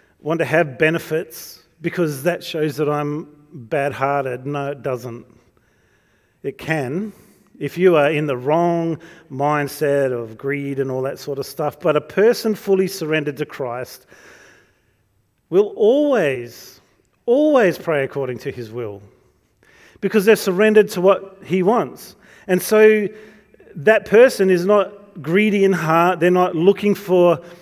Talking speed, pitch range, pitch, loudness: 145 wpm, 140-195 Hz, 165 Hz, -18 LUFS